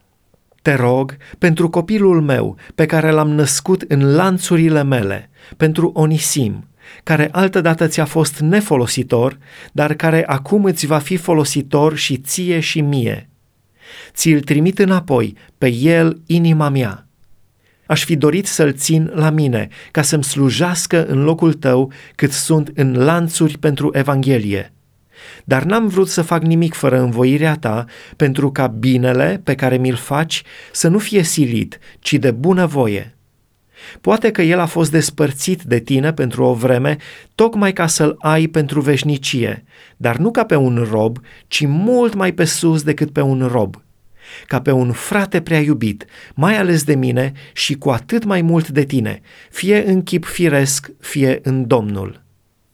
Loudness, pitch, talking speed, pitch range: -15 LUFS, 150 Hz, 155 wpm, 130-165 Hz